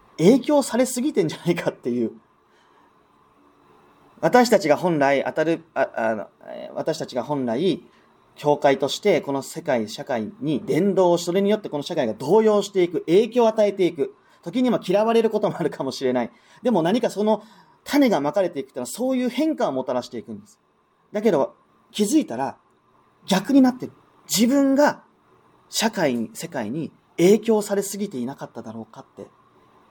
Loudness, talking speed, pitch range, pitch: -22 LUFS, 340 characters per minute, 135-225 Hz, 185 Hz